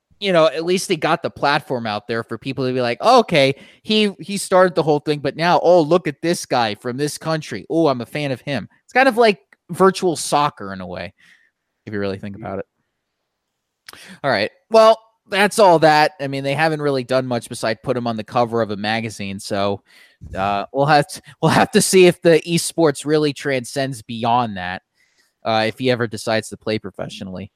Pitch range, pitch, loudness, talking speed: 110-165 Hz, 140 Hz, -18 LUFS, 220 wpm